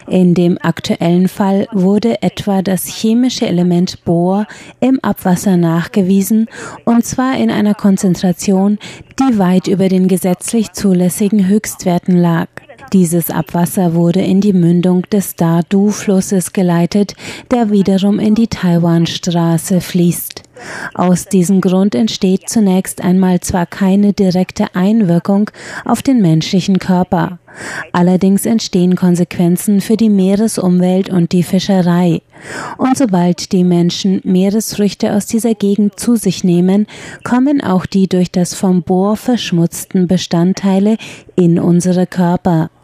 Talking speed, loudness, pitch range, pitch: 120 wpm, -13 LUFS, 175-205 Hz, 190 Hz